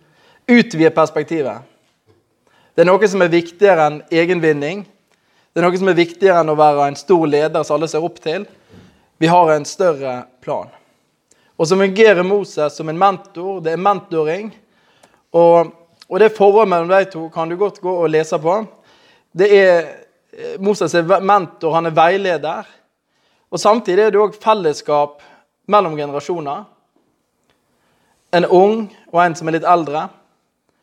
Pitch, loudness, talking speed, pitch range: 175 Hz, -15 LUFS, 155 wpm, 160-200 Hz